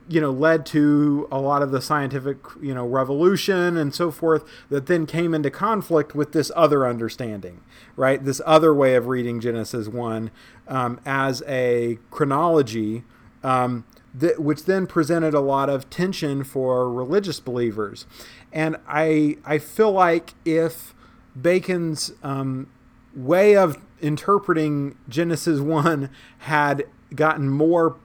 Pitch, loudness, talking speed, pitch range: 145 Hz, -21 LUFS, 135 wpm, 125-160 Hz